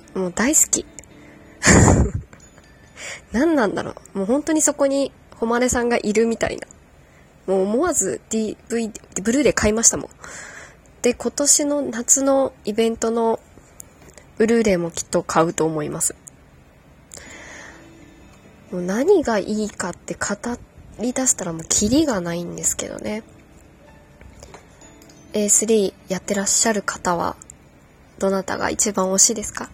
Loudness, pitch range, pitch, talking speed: -19 LUFS, 195-245 Hz, 225 Hz, 250 characters per minute